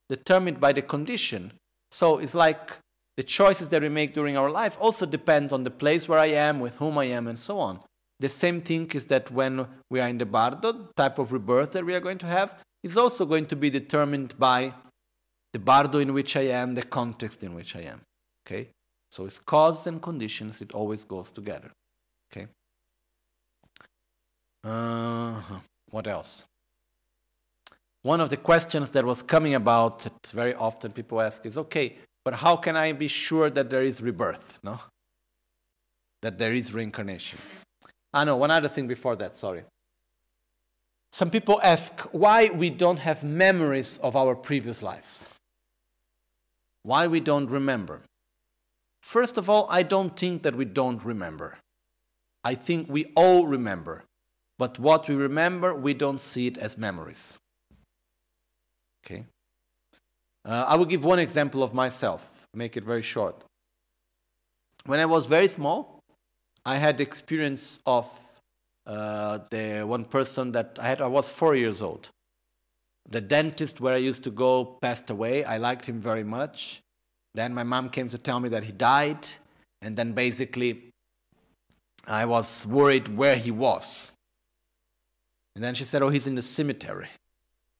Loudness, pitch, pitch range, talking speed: -25 LUFS, 130 Hz, 115-155 Hz, 165 wpm